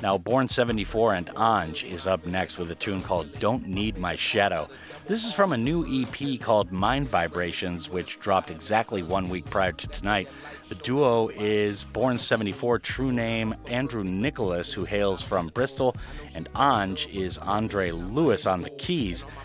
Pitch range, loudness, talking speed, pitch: 90-120 Hz, -26 LUFS, 165 wpm, 105 Hz